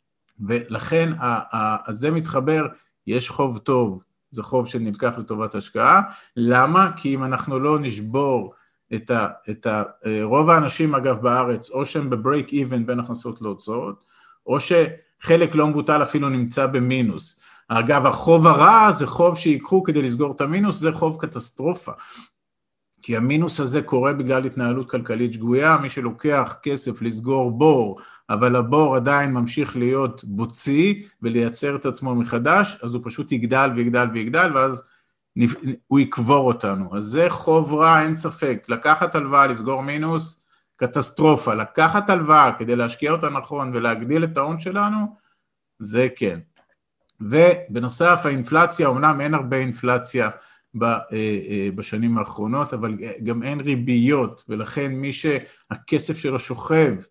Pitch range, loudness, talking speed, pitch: 120-155 Hz, -20 LUFS, 130 wpm, 135 Hz